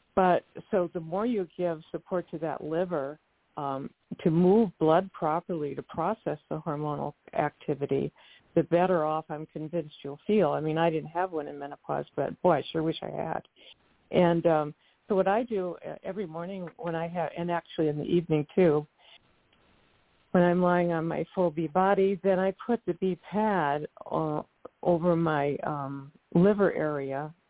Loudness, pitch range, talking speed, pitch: -29 LUFS, 155-185 Hz, 170 wpm, 170 Hz